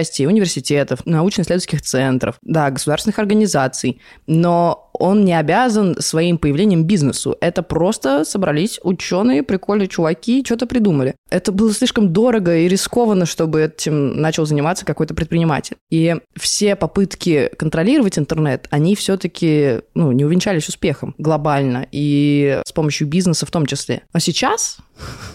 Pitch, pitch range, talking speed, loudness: 165 Hz, 150-195 Hz, 130 wpm, -17 LUFS